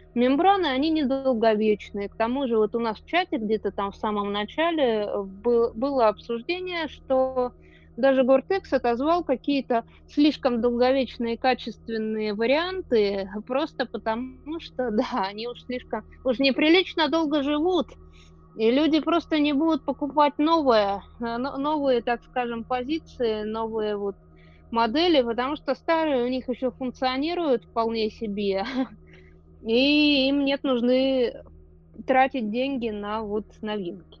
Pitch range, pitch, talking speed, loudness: 220-280 Hz, 250 Hz, 125 wpm, -24 LUFS